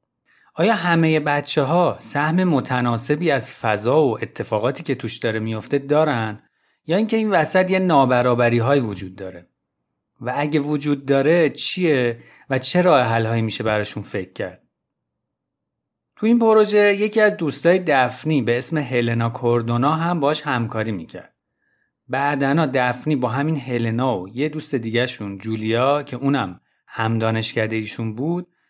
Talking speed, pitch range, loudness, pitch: 145 wpm, 115-155 Hz, -20 LUFS, 135 Hz